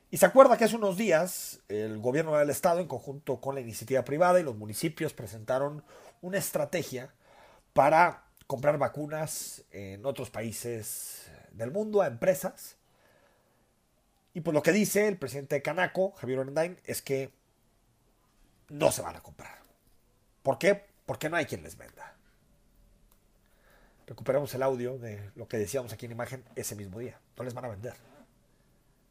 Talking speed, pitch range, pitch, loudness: 160 wpm, 115-170 Hz, 135 Hz, -29 LUFS